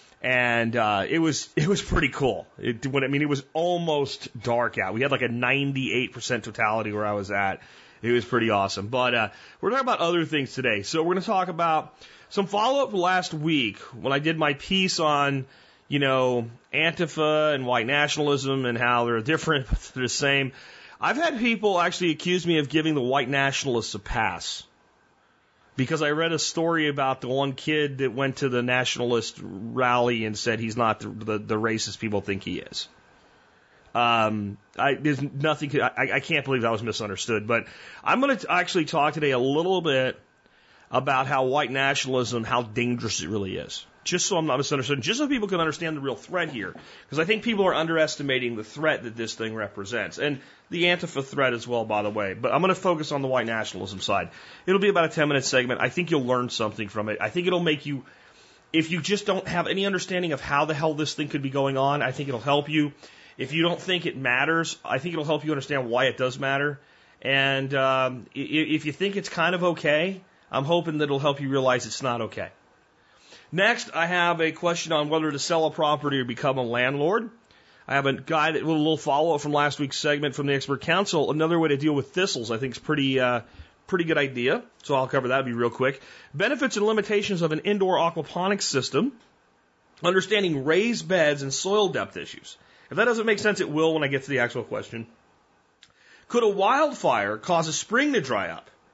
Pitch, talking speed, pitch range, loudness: 140 Hz, 215 wpm, 125-165 Hz, -25 LUFS